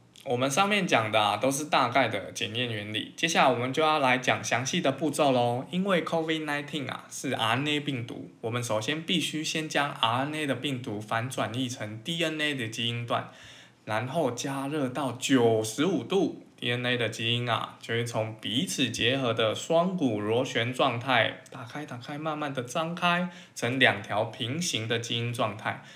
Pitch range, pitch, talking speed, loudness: 115-150 Hz, 130 Hz, 295 characters per minute, -28 LUFS